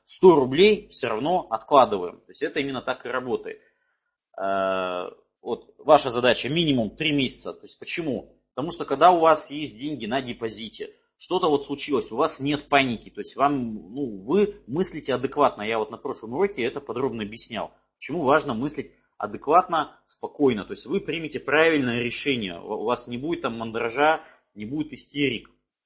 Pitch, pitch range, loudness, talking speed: 145 Hz, 120-165 Hz, -24 LUFS, 170 wpm